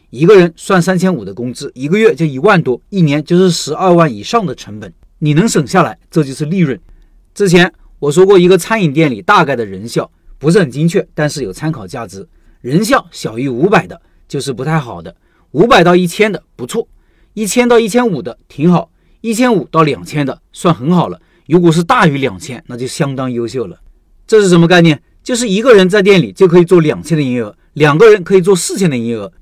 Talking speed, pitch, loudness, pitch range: 320 characters per minute, 165 Hz, -11 LUFS, 135-185 Hz